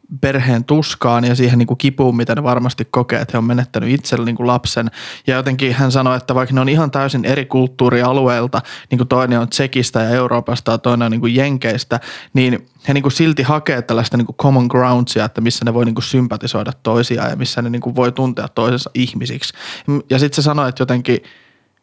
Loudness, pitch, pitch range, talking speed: -16 LUFS, 125 Hz, 120-135 Hz, 210 wpm